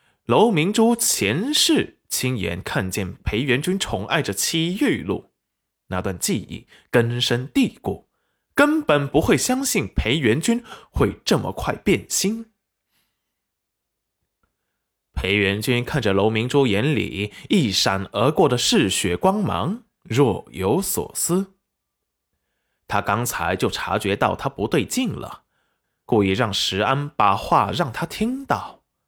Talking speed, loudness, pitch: 180 characters per minute, -21 LUFS, 130 Hz